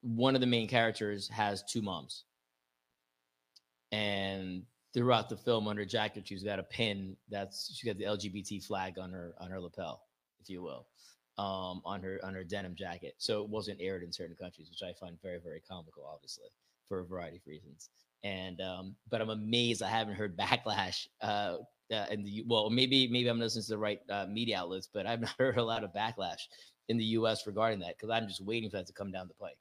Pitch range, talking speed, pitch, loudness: 95-110 Hz, 215 wpm, 100 Hz, -35 LUFS